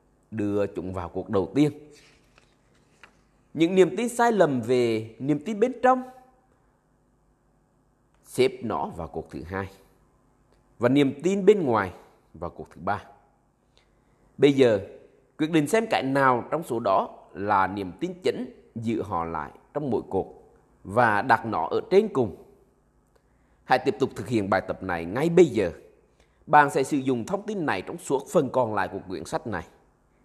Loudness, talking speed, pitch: -25 LUFS, 165 wpm, 150 Hz